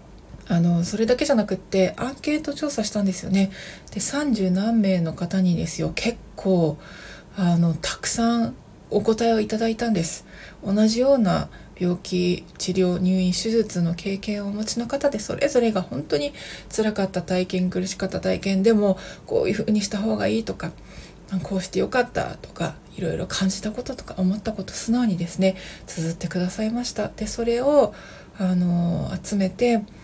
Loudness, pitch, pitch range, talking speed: -22 LUFS, 195 Hz, 185-230 Hz, 340 characters per minute